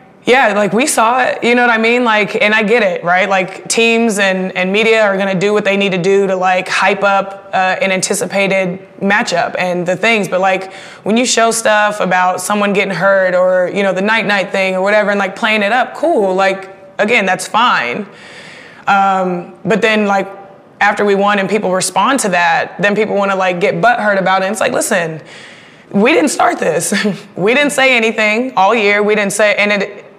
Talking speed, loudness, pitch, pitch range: 220 wpm, -12 LUFS, 200 Hz, 190-215 Hz